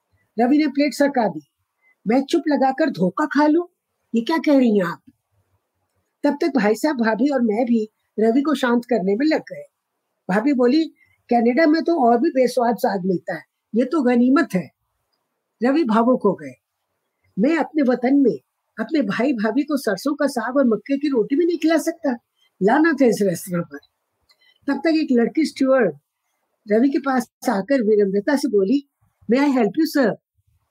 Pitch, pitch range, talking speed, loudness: 260 Hz, 225-295 Hz, 180 wpm, -19 LUFS